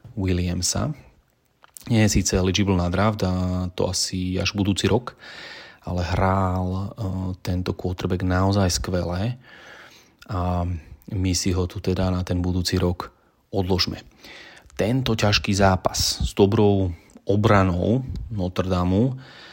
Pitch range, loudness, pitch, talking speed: 90-100 Hz, -23 LUFS, 95 Hz, 115 wpm